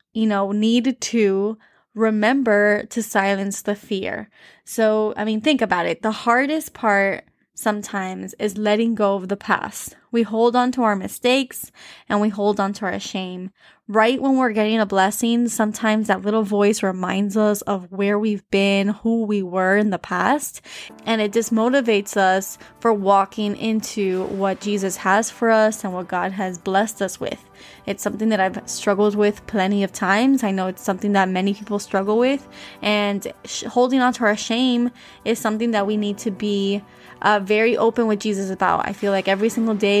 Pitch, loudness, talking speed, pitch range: 210 Hz, -20 LUFS, 185 wpm, 195-225 Hz